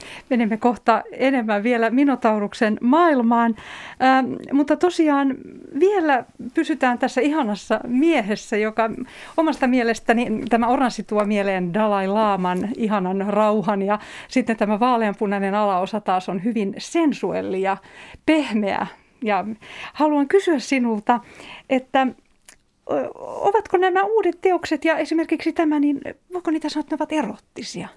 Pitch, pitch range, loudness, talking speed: 245 Hz, 215-305 Hz, -21 LUFS, 120 wpm